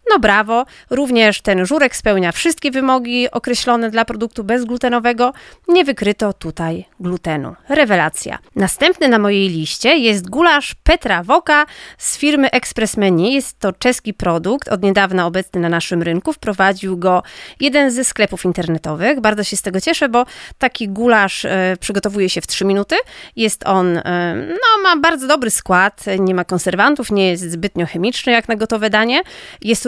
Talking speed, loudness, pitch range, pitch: 160 wpm, -15 LUFS, 190-260 Hz, 220 Hz